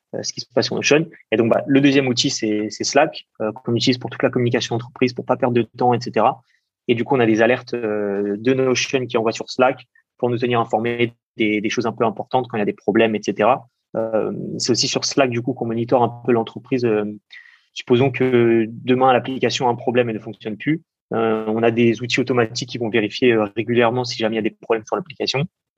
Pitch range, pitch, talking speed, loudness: 110-125 Hz, 120 Hz, 240 wpm, -19 LUFS